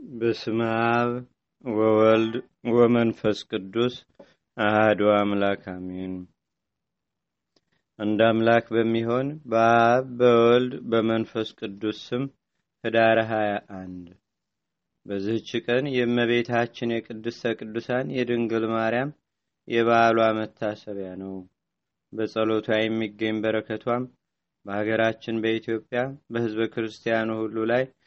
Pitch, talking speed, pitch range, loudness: 115 Hz, 75 wpm, 110-120 Hz, -24 LUFS